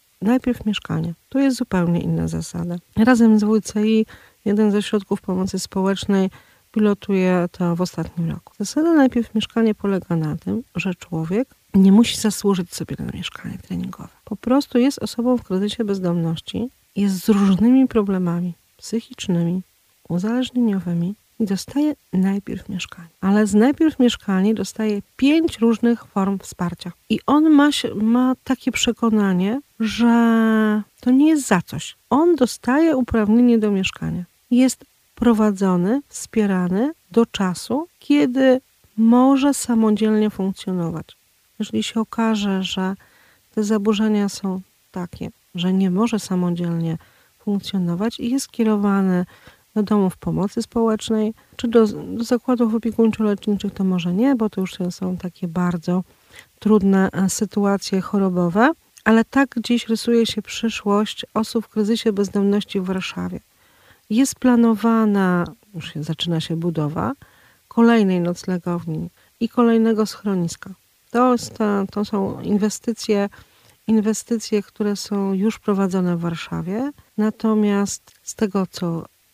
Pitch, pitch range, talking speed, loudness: 210 Hz, 185-230 Hz, 125 wpm, -20 LUFS